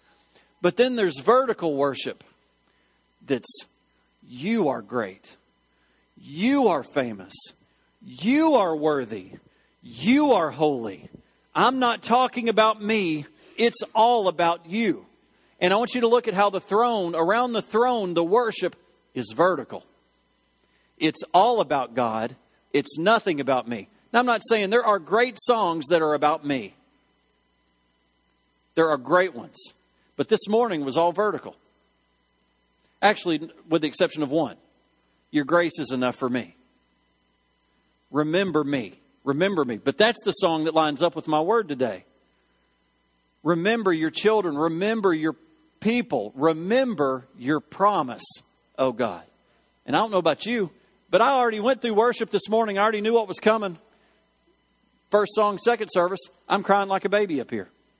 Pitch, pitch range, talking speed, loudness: 175 Hz, 140-220 Hz, 150 wpm, -23 LUFS